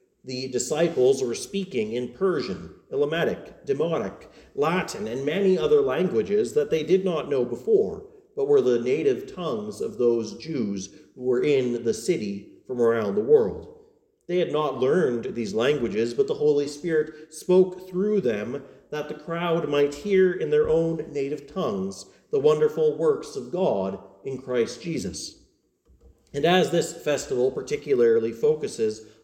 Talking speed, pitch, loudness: 150 wpm, 190 Hz, -25 LUFS